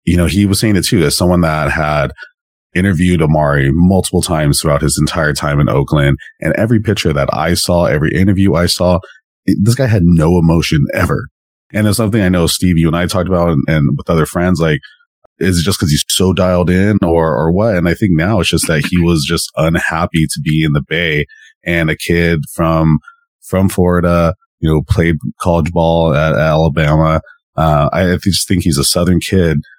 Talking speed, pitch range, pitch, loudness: 210 wpm, 80-95 Hz, 85 Hz, -13 LUFS